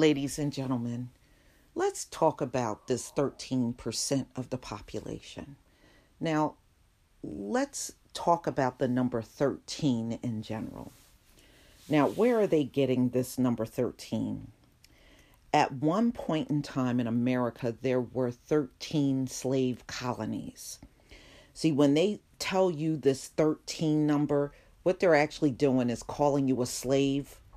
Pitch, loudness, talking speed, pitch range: 135 Hz, -30 LUFS, 125 wpm, 125-150 Hz